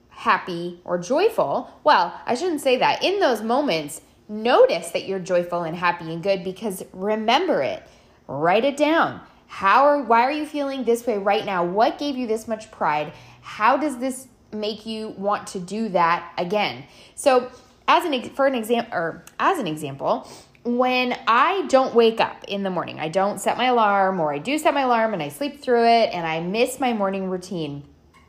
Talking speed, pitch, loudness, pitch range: 195 wpm, 220 Hz, -22 LUFS, 185-255 Hz